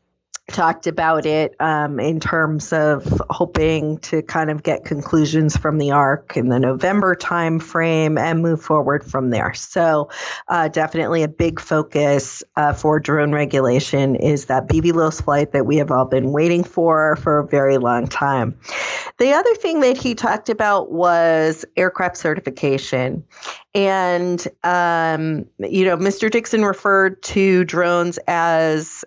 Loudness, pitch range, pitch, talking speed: -18 LUFS, 145-175 Hz, 160 Hz, 150 wpm